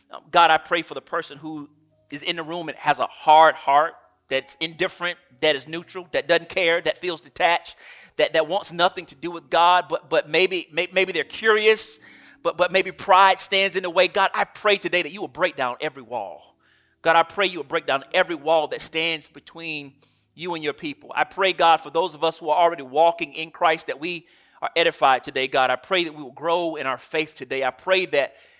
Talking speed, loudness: 230 wpm, -21 LUFS